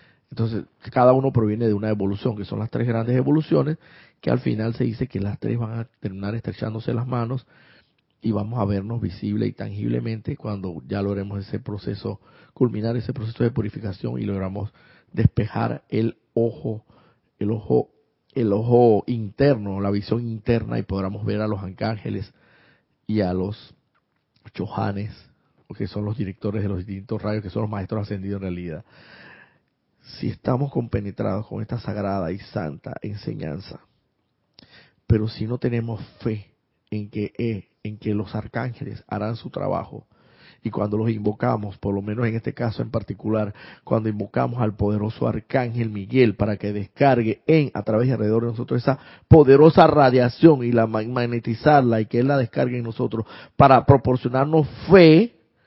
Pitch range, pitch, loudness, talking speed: 105-120 Hz, 110 Hz, -22 LUFS, 160 wpm